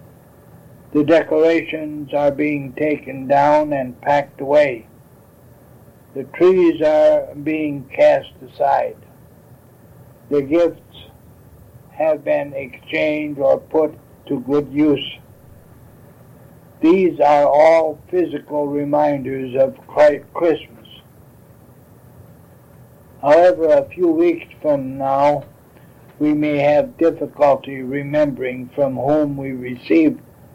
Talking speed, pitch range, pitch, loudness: 90 wpm, 135-155 Hz, 145 Hz, -17 LUFS